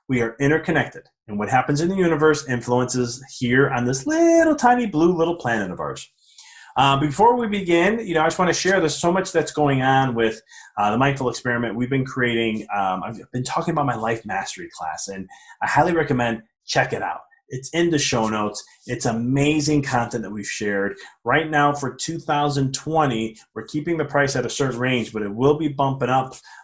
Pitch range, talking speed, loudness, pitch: 120-155 Hz, 205 wpm, -21 LUFS, 135 Hz